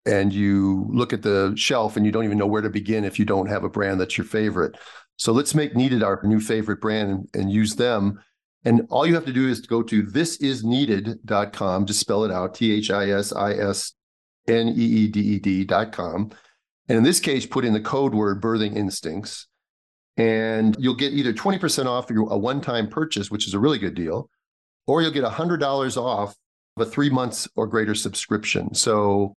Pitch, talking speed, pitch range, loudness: 110 Hz, 190 wpm, 100-125 Hz, -22 LUFS